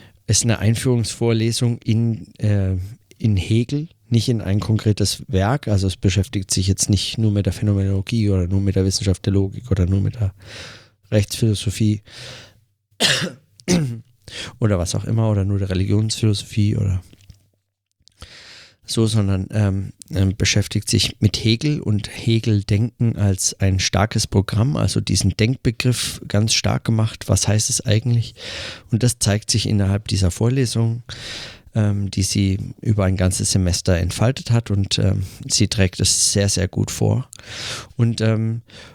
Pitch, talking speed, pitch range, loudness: 105 Hz, 145 wpm, 100-115 Hz, -20 LUFS